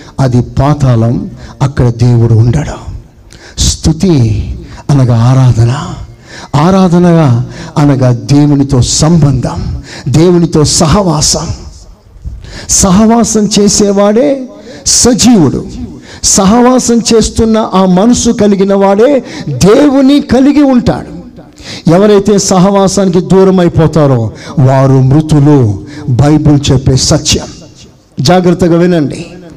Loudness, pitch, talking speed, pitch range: -7 LUFS, 160 Hz, 75 wpm, 130-200 Hz